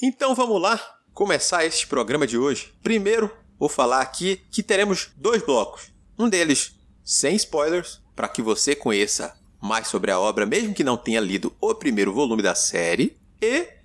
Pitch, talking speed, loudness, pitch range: 210 Hz, 170 wpm, -22 LUFS, 175-260 Hz